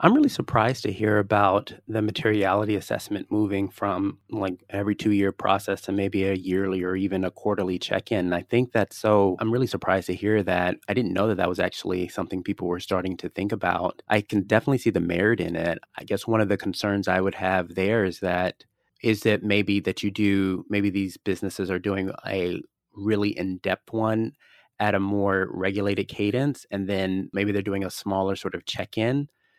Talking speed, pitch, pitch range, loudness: 200 wpm, 100 Hz, 95-105 Hz, -25 LUFS